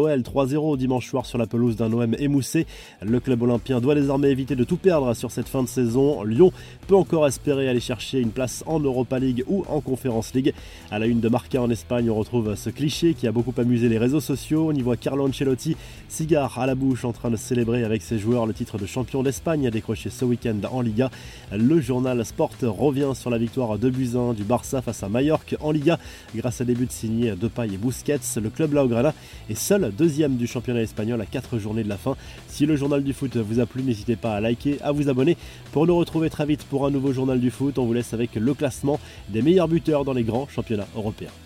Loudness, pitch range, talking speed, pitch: -23 LUFS, 115-140 Hz, 235 wpm, 125 Hz